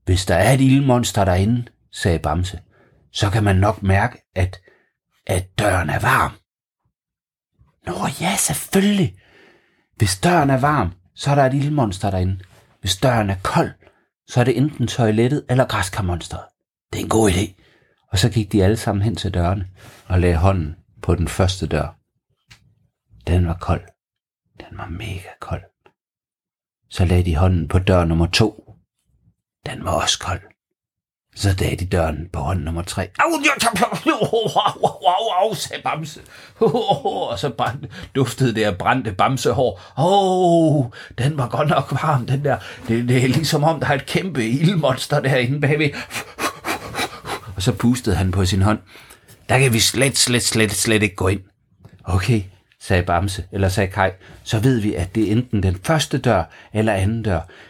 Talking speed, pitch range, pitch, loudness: 175 wpm, 95-130 Hz, 105 Hz, -19 LUFS